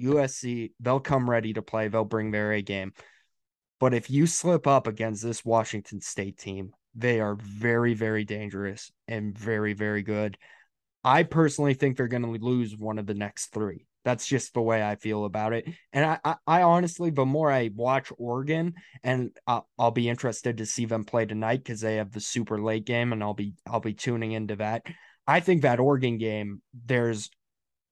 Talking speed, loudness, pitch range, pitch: 195 wpm, -27 LUFS, 105-130 Hz, 115 Hz